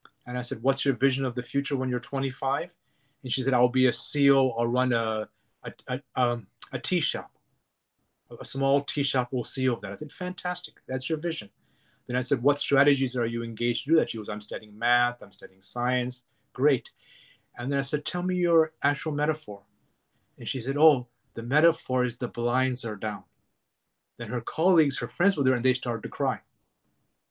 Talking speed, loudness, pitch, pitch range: 205 wpm, -27 LUFS, 130 Hz, 120-140 Hz